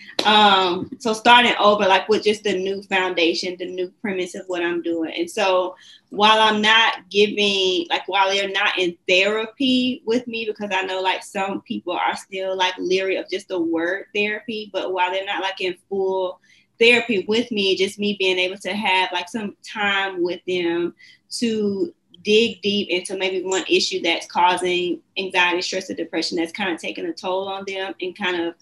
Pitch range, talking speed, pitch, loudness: 180-210 Hz, 190 wpm, 190 Hz, -20 LUFS